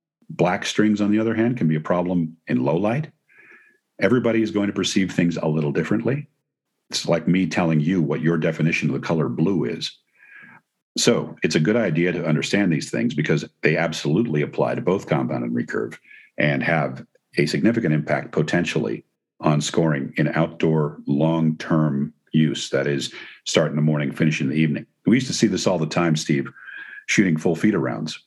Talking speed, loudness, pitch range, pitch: 190 wpm, -21 LUFS, 75-95 Hz, 80 Hz